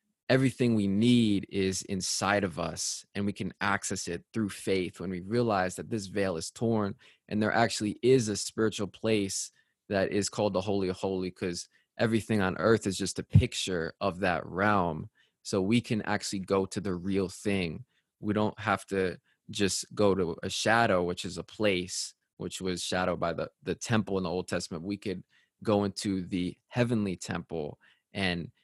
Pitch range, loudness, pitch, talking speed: 90-105 Hz, -30 LUFS, 100 Hz, 185 wpm